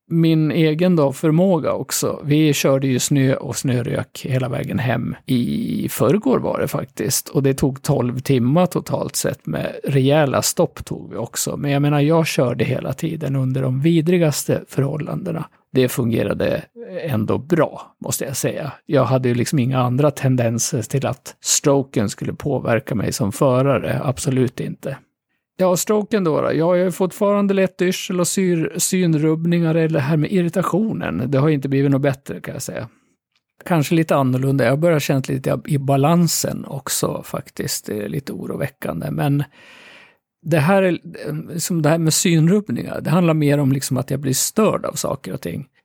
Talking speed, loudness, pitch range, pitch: 170 wpm, -19 LUFS, 135-170 Hz, 150 Hz